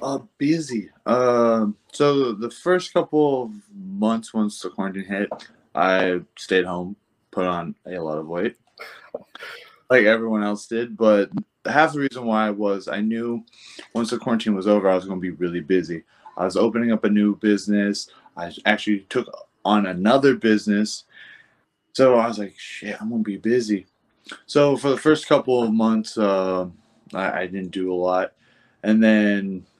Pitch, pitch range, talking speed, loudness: 110 Hz, 100-120 Hz, 170 wpm, -21 LUFS